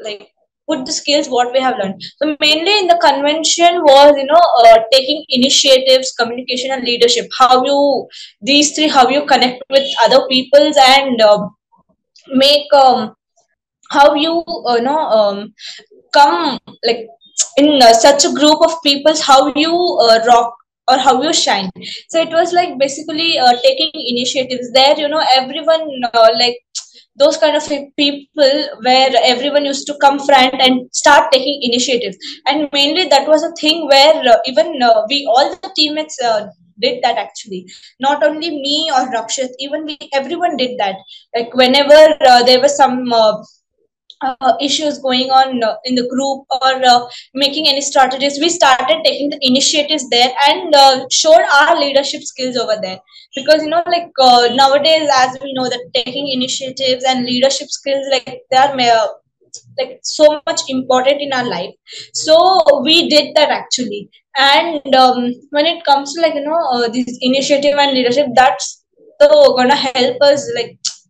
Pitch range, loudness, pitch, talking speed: 255-305 Hz, -12 LUFS, 275 Hz, 170 wpm